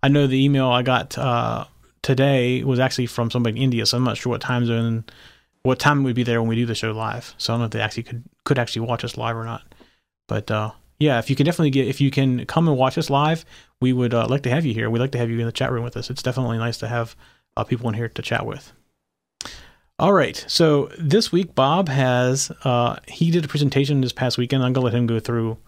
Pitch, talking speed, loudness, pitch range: 125 Hz, 270 wpm, -21 LUFS, 115-135 Hz